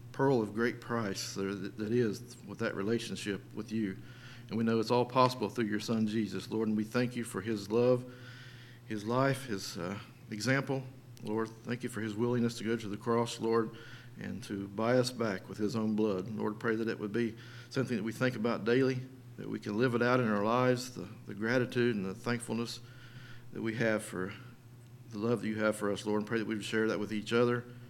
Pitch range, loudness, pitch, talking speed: 110-120 Hz, -33 LUFS, 115 Hz, 225 wpm